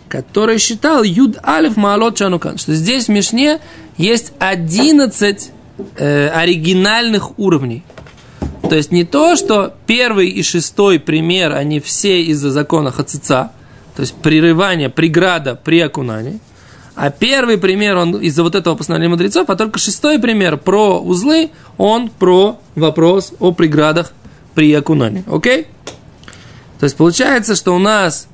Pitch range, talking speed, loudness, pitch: 155-210 Hz, 135 wpm, -12 LUFS, 175 Hz